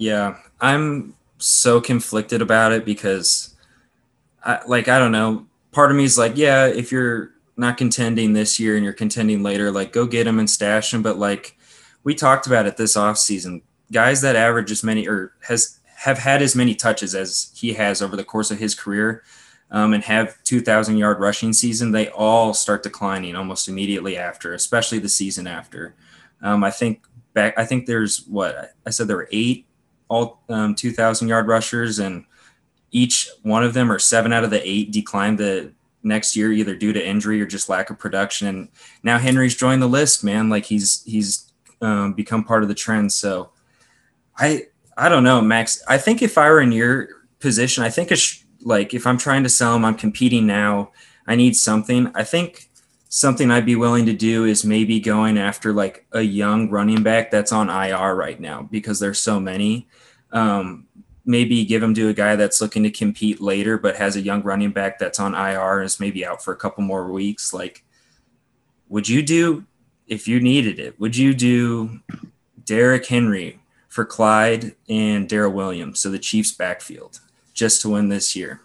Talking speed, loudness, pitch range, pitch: 195 wpm, -18 LUFS, 105-120 Hz, 110 Hz